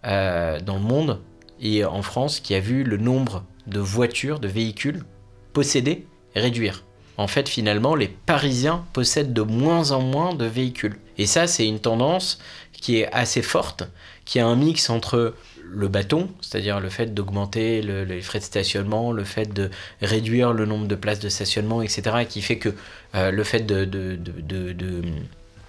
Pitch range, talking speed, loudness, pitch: 100-125 Hz, 180 wpm, -23 LUFS, 110 Hz